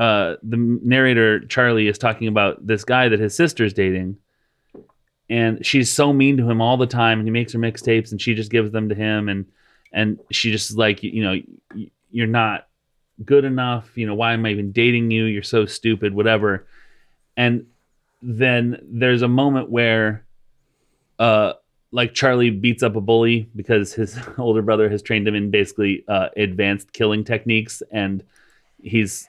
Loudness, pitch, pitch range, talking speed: -19 LUFS, 115 Hz, 105-120 Hz, 180 wpm